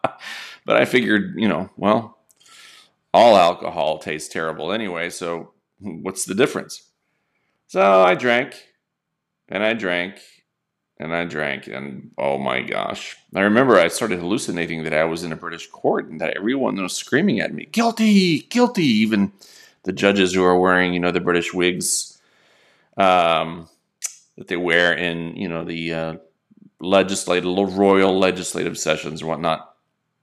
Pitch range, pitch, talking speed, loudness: 85-95 Hz, 90 Hz, 150 wpm, -20 LUFS